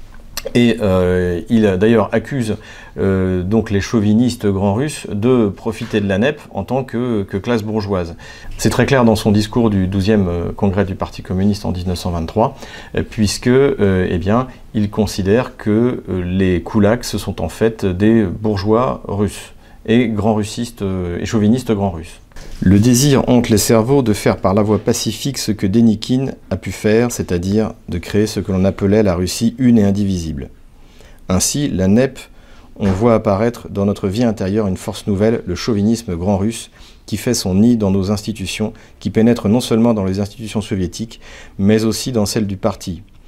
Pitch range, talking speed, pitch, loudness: 95-115 Hz, 170 wpm, 105 Hz, -16 LUFS